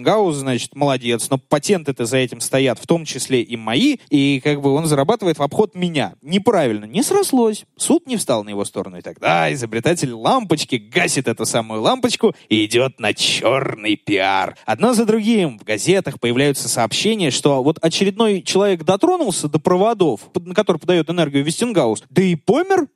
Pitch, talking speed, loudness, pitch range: 160 Hz, 170 wpm, -18 LUFS, 130-205 Hz